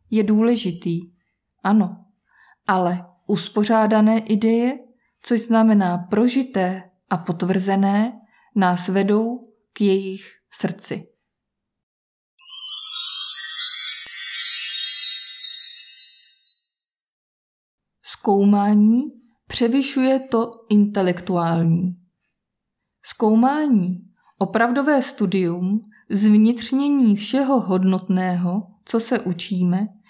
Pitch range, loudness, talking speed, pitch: 180-225 Hz, -19 LUFS, 60 wpm, 200 Hz